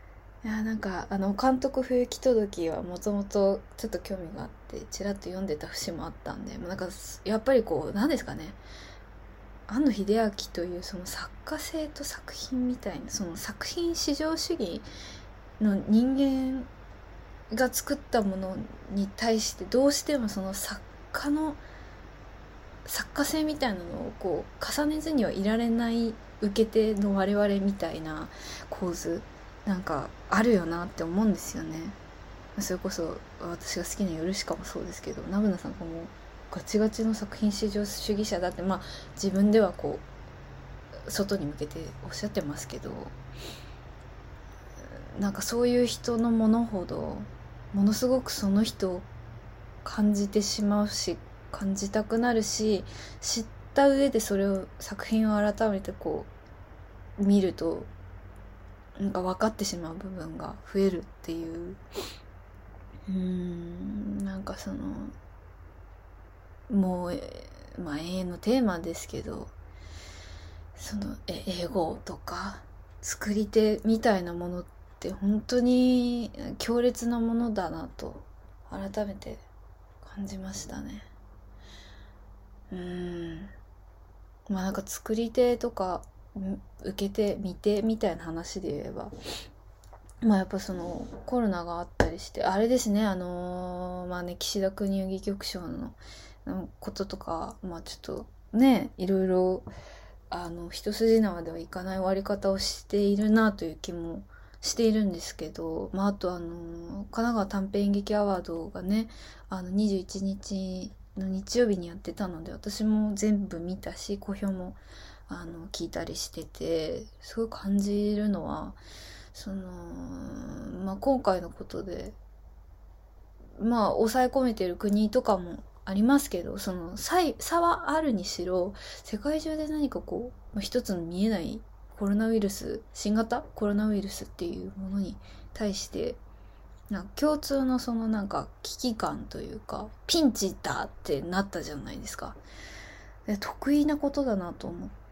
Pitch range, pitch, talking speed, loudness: 165-220 Hz, 195 Hz, 265 characters per minute, -30 LUFS